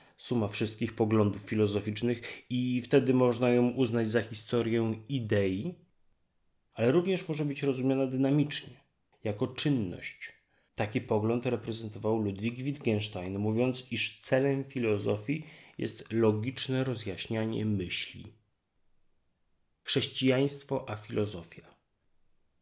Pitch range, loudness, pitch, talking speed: 105-130 Hz, -30 LUFS, 115 Hz, 95 wpm